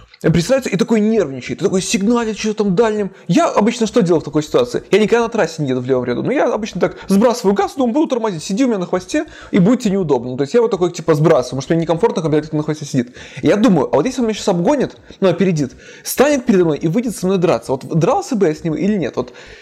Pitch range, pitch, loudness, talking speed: 160-225 Hz, 195 Hz, -16 LUFS, 270 wpm